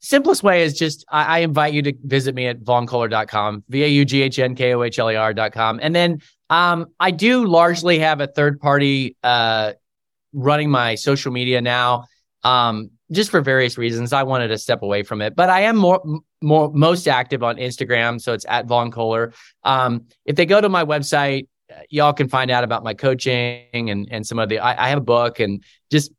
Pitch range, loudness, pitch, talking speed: 120-150 Hz, -18 LUFS, 130 Hz, 190 wpm